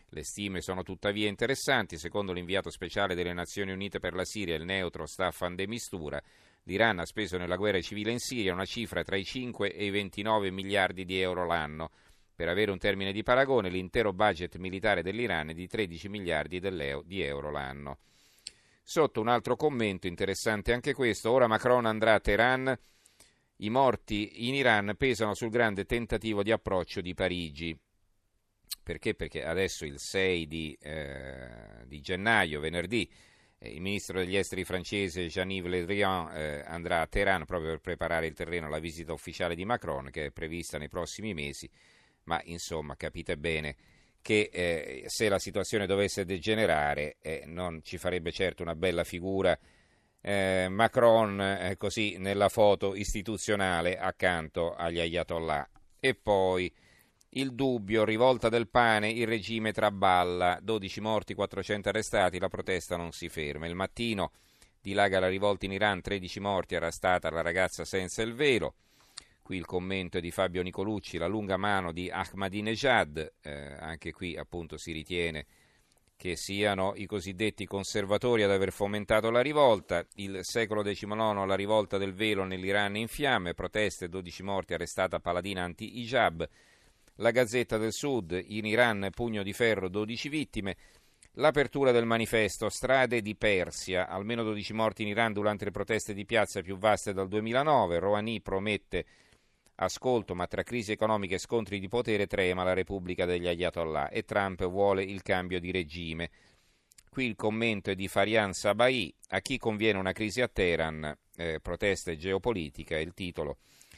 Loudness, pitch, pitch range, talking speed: -30 LUFS, 95 Hz, 90-110 Hz, 155 wpm